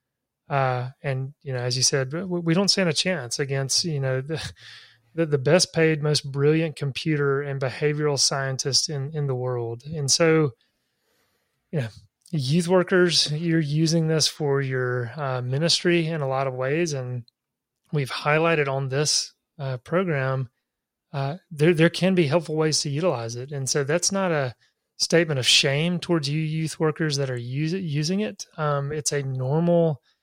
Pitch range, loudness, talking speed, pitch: 130-165 Hz, -23 LUFS, 170 wpm, 145 Hz